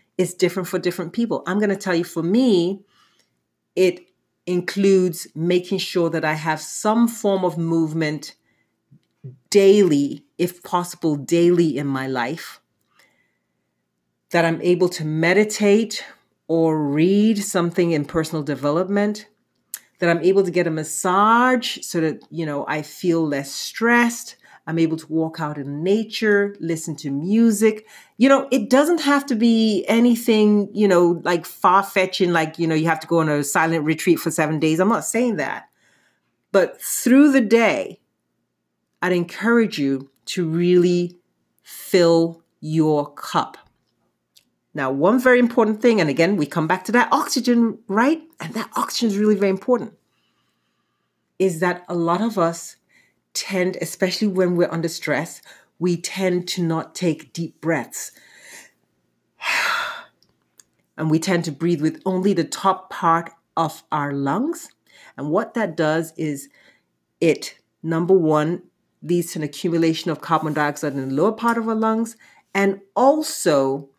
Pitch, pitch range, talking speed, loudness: 175 Hz, 160-210 Hz, 150 wpm, -20 LUFS